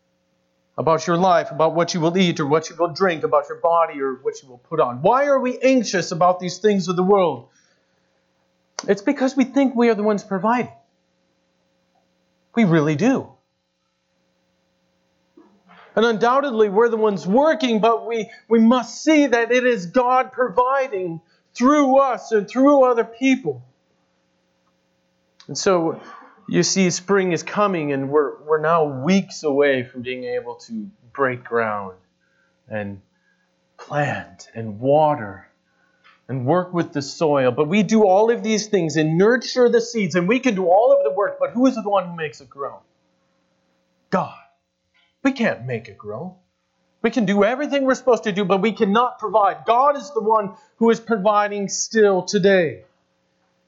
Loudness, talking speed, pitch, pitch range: -19 LUFS, 165 wpm, 195 Hz, 155-230 Hz